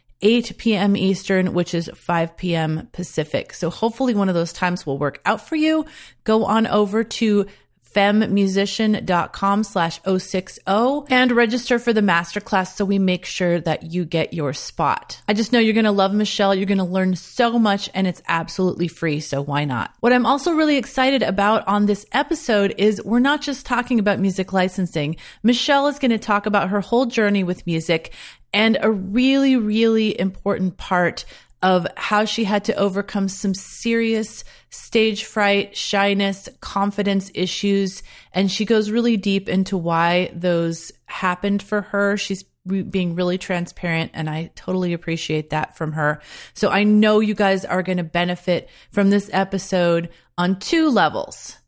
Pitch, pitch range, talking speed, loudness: 200 Hz, 180-220 Hz, 170 wpm, -20 LUFS